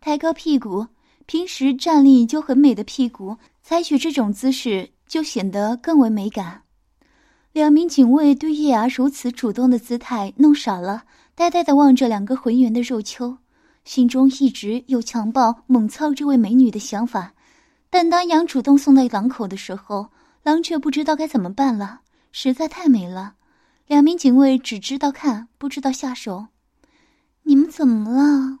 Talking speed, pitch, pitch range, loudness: 245 characters per minute, 265 Hz, 235-305 Hz, -18 LUFS